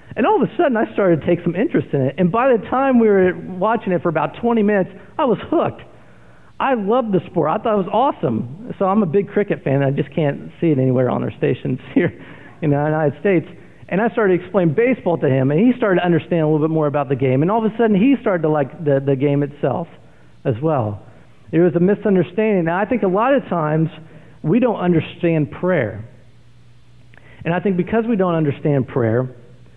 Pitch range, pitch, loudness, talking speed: 145-205 Hz, 175 Hz, -18 LUFS, 235 wpm